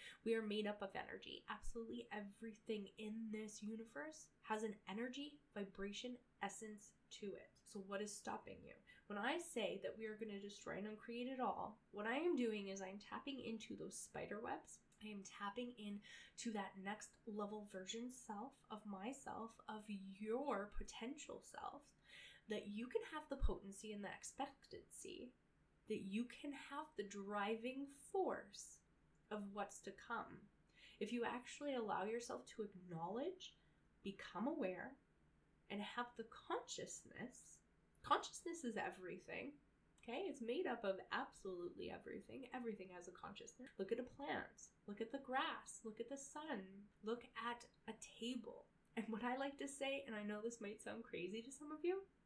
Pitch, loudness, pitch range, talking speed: 225 Hz, -49 LUFS, 205-255 Hz, 165 wpm